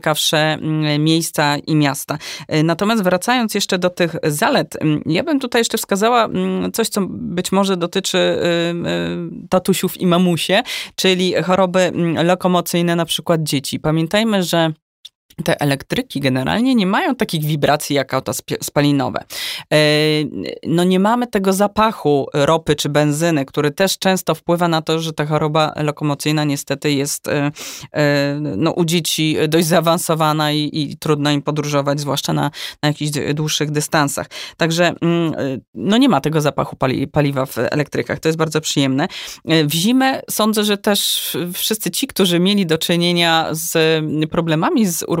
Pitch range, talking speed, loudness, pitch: 150-185 Hz, 140 wpm, -17 LUFS, 160 Hz